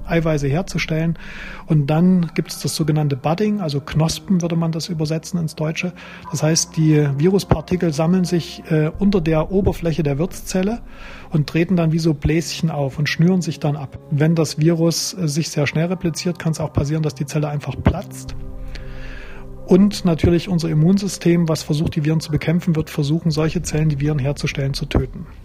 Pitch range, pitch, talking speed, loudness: 150-170 Hz, 160 Hz, 175 wpm, -19 LUFS